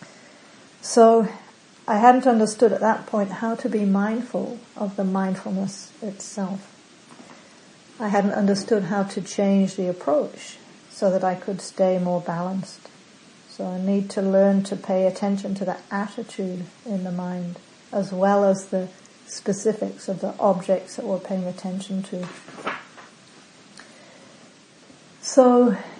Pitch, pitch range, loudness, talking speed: 200 Hz, 190-215 Hz, -23 LUFS, 135 wpm